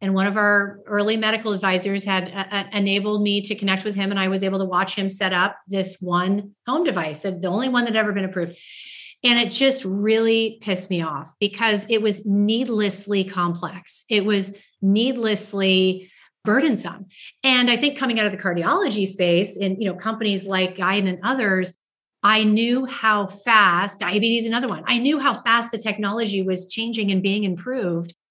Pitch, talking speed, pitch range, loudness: 200 Hz, 185 wpm, 190-220 Hz, -21 LUFS